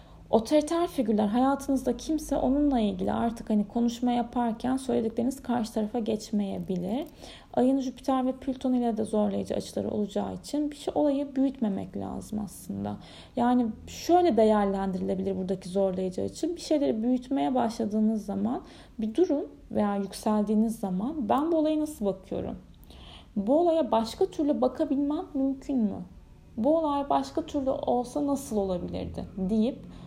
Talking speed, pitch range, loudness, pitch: 130 wpm, 215-280 Hz, -28 LUFS, 245 Hz